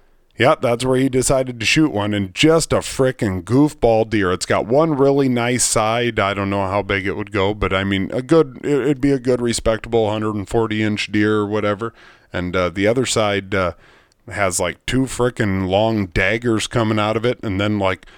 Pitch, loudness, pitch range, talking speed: 110 Hz, -18 LUFS, 100-125 Hz, 210 wpm